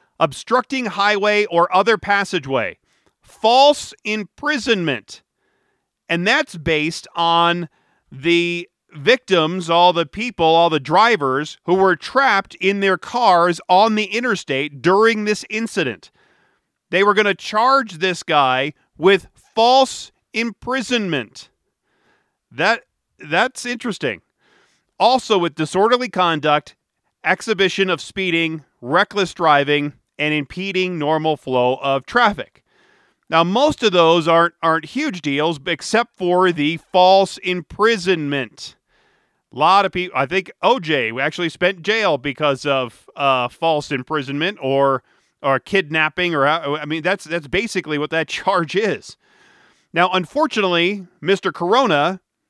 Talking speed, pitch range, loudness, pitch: 120 wpm, 155-210 Hz, -18 LUFS, 180 Hz